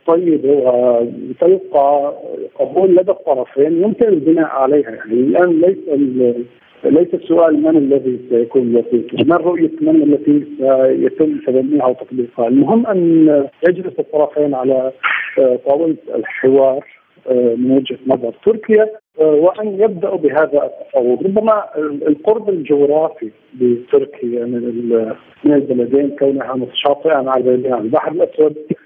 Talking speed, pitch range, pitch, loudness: 105 wpm, 130-180 Hz, 145 Hz, -14 LUFS